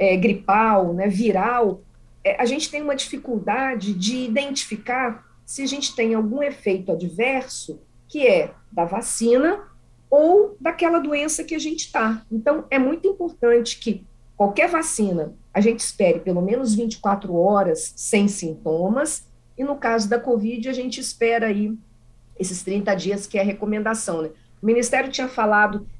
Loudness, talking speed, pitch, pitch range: -21 LUFS, 155 wpm, 230 Hz, 200-275 Hz